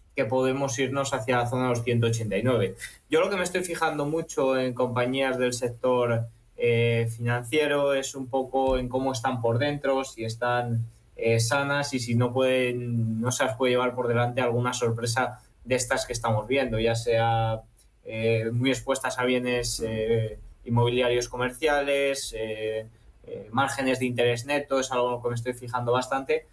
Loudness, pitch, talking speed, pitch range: -26 LUFS, 125 Hz, 170 wpm, 115-135 Hz